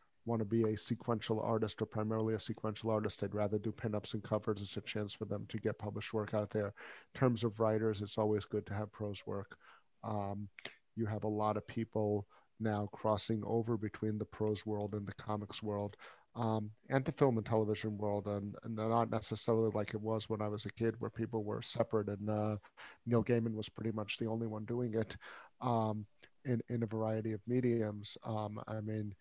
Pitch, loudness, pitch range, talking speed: 110 Hz, -38 LUFS, 105-115 Hz, 210 wpm